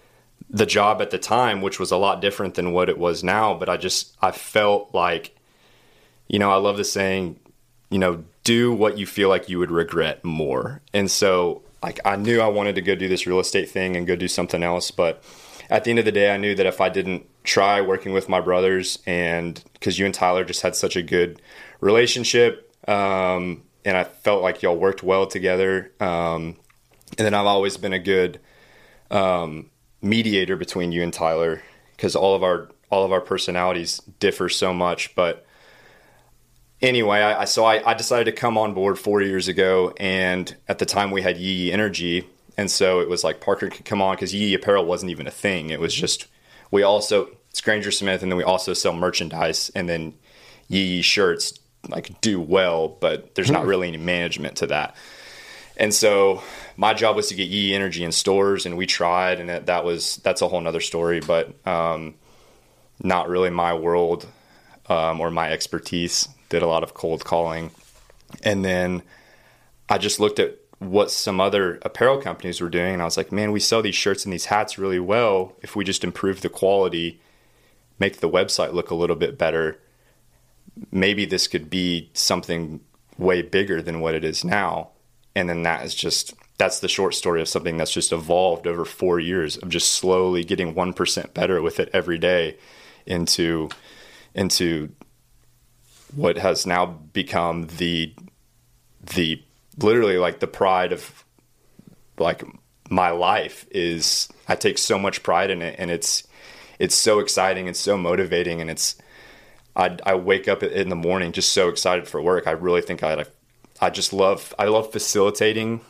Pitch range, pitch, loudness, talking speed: 85-100 Hz, 95 Hz, -21 LUFS, 190 wpm